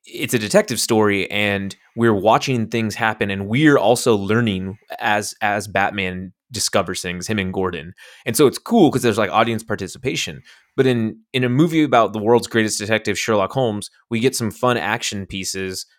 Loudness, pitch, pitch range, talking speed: -19 LUFS, 110 Hz, 95-115 Hz, 180 wpm